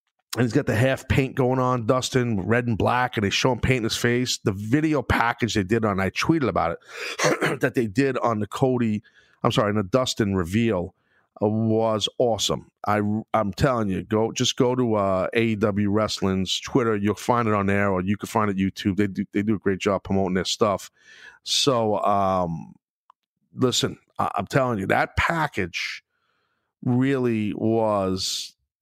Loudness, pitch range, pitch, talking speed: -23 LUFS, 100-125 Hz, 110 Hz, 180 wpm